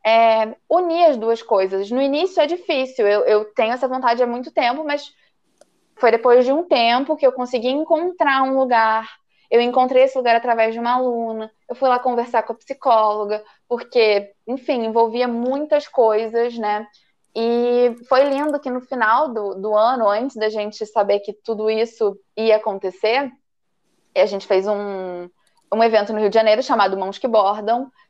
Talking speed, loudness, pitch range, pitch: 175 wpm, -19 LUFS, 215-260 Hz, 235 Hz